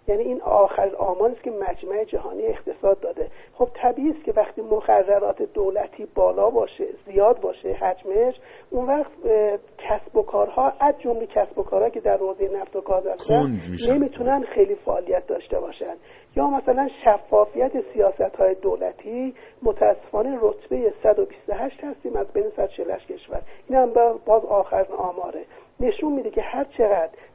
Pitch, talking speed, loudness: 260 Hz, 150 wpm, -22 LUFS